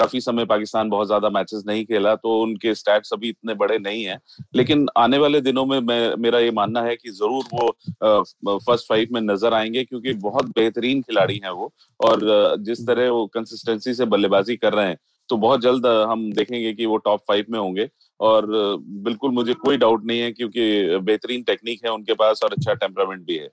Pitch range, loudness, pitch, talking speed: 110-125 Hz, -20 LUFS, 115 Hz, 205 wpm